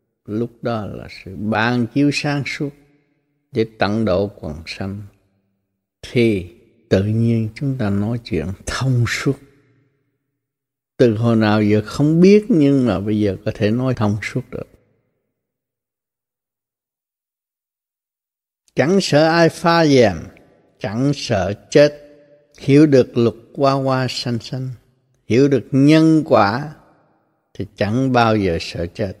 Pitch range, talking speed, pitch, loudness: 105-140 Hz, 130 wpm, 120 Hz, -17 LUFS